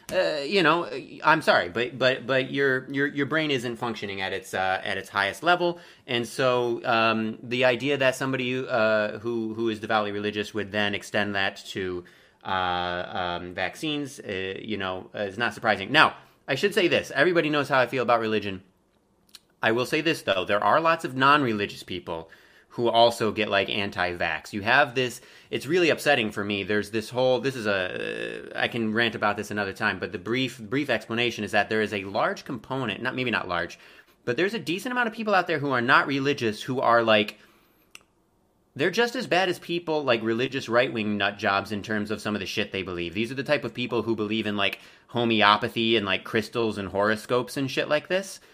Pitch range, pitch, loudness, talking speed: 105-135 Hz, 115 Hz, -25 LUFS, 210 wpm